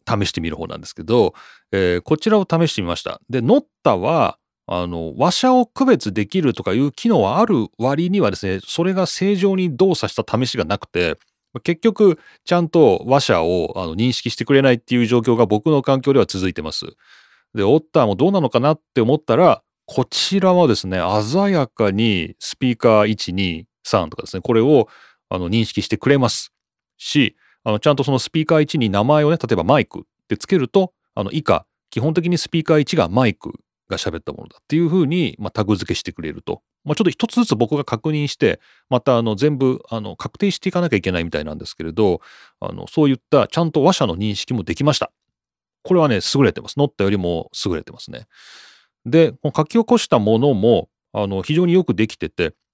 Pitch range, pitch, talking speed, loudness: 105-165 Hz, 130 Hz, 400 characters per minute, -18 LUFS